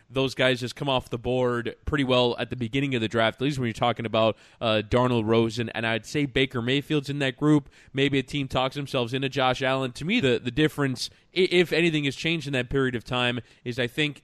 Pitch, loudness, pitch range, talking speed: 130 Hz, -25 LUFS, 120-140 Hz, 240 wpm